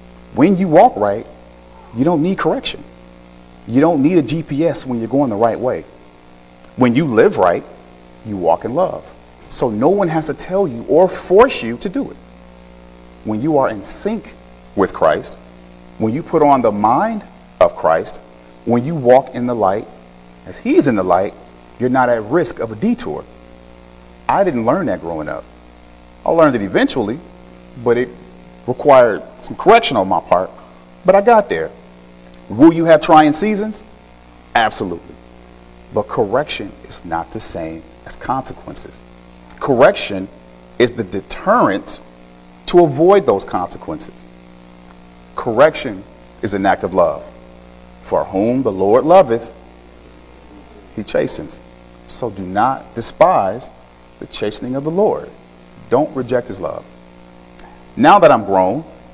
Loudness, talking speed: -15 LUFS, 150 wpm